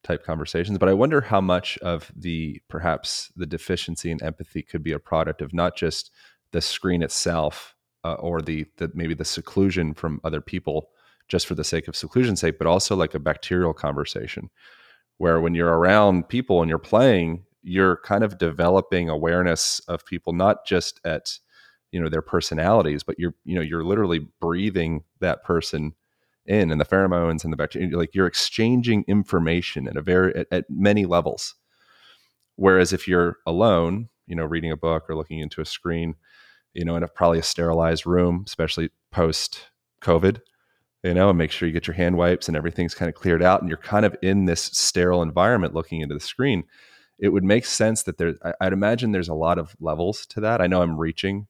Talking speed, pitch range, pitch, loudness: 195 wpm, 80-95 Hz, 85 Hz, -23 LUFS